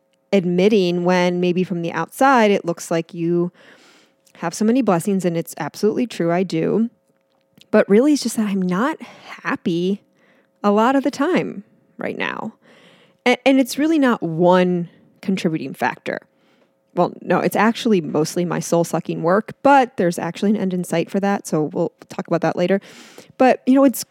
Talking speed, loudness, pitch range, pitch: 175 wpm, -19 LUFS, 175-225 Hz, 190 Hz